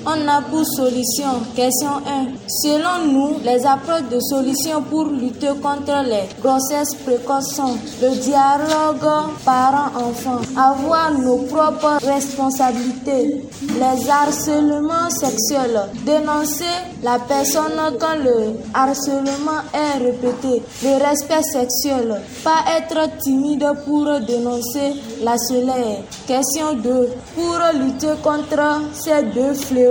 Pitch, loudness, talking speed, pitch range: 275 Hz, -18 LUFS, 110 wpm, 255-300 Hz